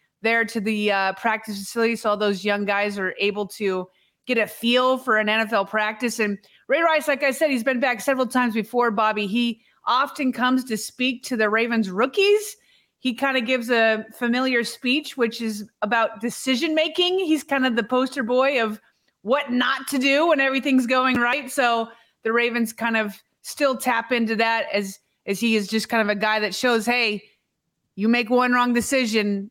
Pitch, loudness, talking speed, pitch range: 235 Hz, -22 LUFS, 195 wpm, 220-260 Hz